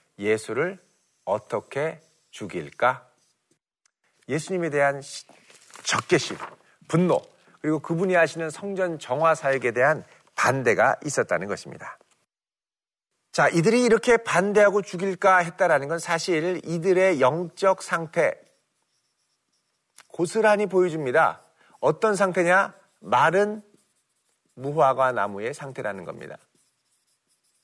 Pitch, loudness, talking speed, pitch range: 175 Hz, -23 LUFS, 230 characters per minute, 155-195 Hz